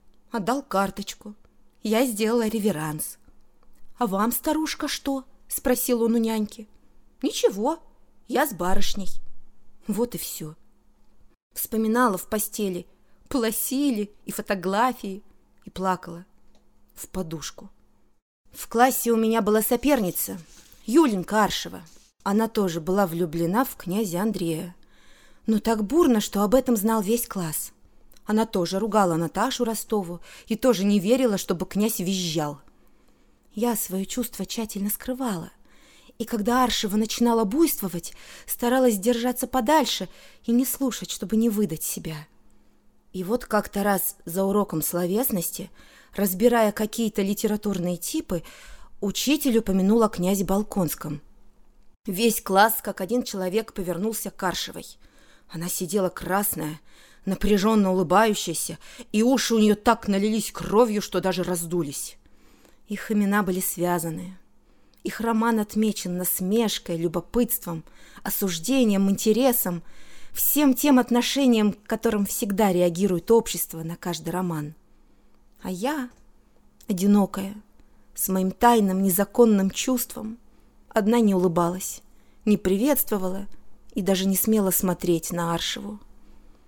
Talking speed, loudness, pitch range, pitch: 115 wpm, -24 LUFS, 185-230 Hz, 205 Hz